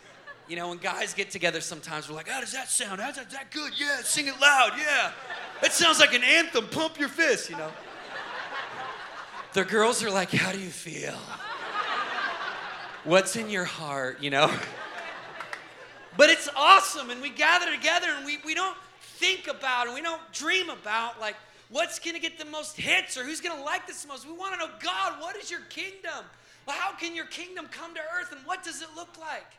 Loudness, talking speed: -26 LUFS, 215 wpm